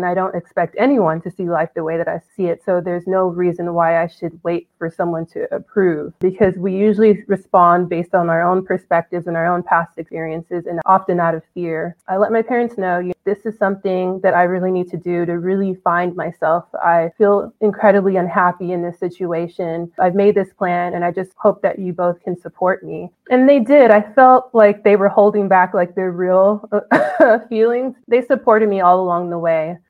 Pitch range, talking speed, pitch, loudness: 175-200 Hz, 210 wpm, 185 Hz, -16 LUFS